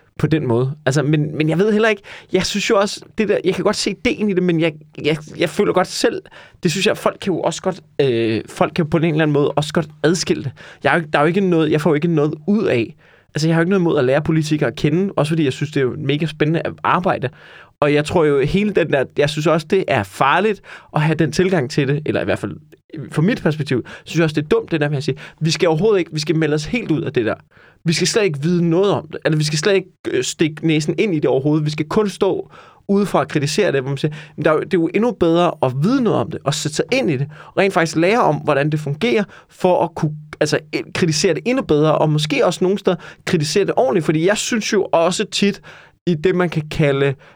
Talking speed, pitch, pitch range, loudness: 280 wpm, 165 Hz, 150-185 Hz, -18 LUFS